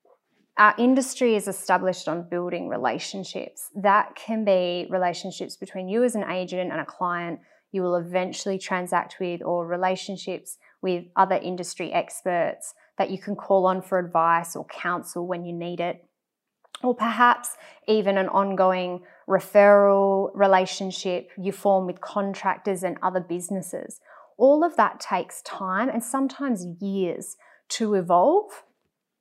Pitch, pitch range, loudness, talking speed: 190 Hz, 180-205 Hz, -24 LUFS, 140 wpm